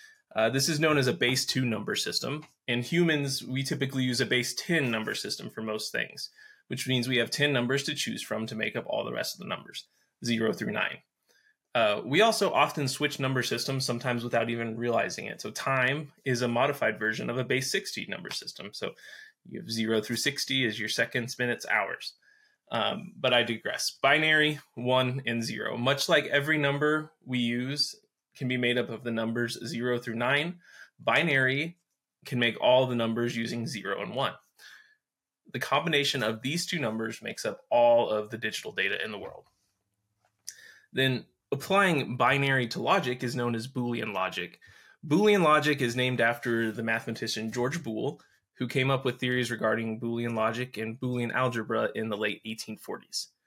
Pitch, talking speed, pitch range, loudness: 125 Hz, 185 wpm, 115-145 Hz, -28 LUFS